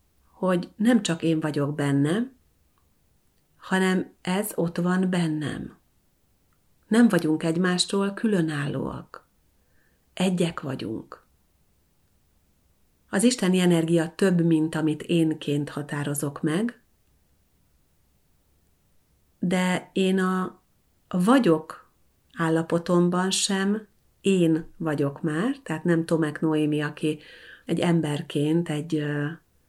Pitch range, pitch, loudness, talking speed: 140-185 Hz, 160 Hz, -25 LUFS, 85 wpm